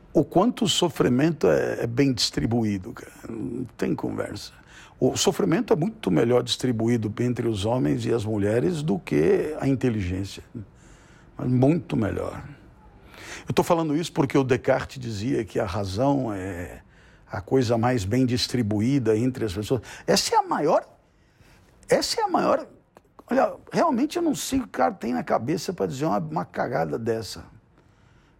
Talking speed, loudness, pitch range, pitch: 160 wpm, -24 LUFS, 110-155 Hz, 125 Hz